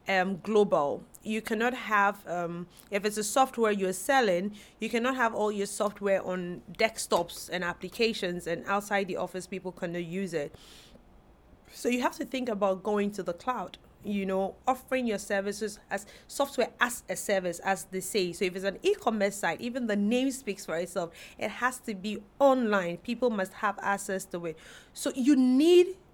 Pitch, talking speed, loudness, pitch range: 205 Hz, 180 wpm, -29 LUFS, 190-240 Hz